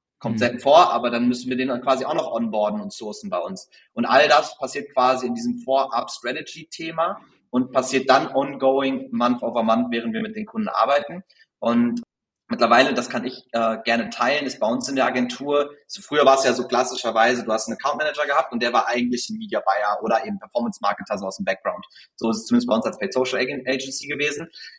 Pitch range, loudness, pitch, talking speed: 115-145 Hz, -22 LUFS, 130 Hz, 210 wpm